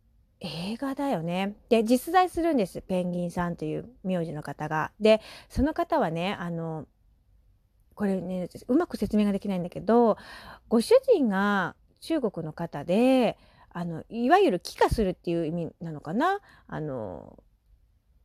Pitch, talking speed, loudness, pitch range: 190 Hz, 275 characters per minute, -27 LUFS, 165-235 Hz